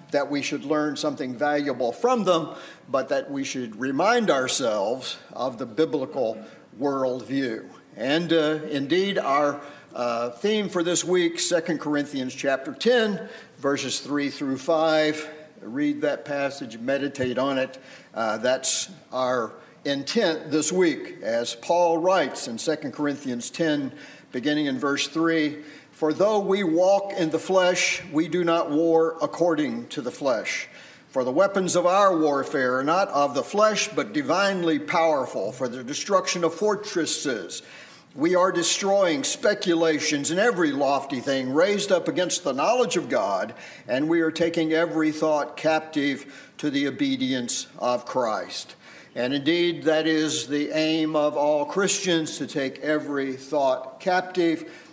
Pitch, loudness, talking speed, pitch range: 155 Hz, -24 LUFS, 145 wpm, 140-180 Hz